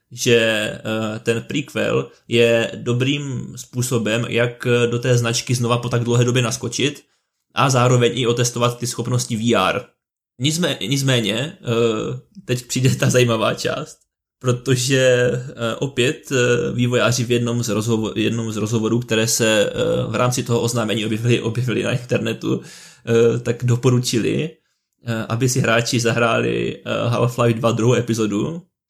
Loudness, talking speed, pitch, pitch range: -19 LUFS, 115 wpm, 120 Hz, 115-125 Hz